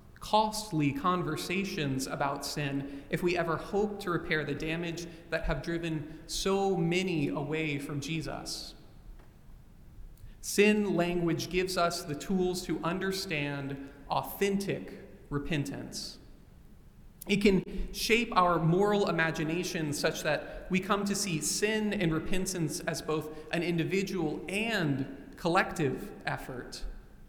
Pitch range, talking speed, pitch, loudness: 155-190 Hz, 115 wpm, 165 Hz, -31 LUFS